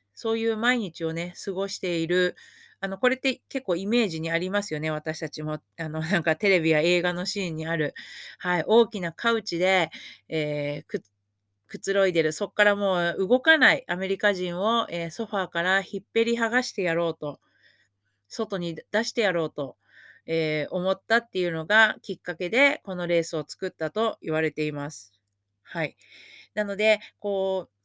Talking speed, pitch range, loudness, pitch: 340 characters per minute, 160-210 Hz, -25 LUFS, 180 Hz